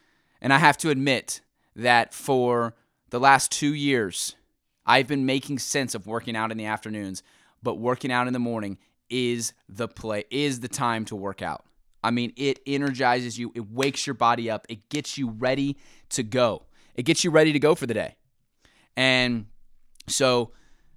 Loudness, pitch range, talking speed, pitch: -24 LUFS, 115-135 Hz, 180 wpm, 125 Hz